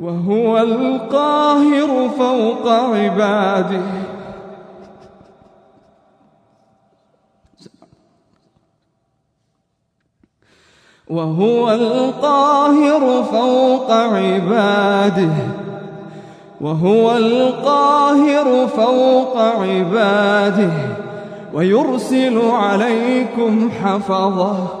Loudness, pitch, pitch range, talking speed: -15 LUFS, 225 Hz, 195-255 Hz, 35 wpm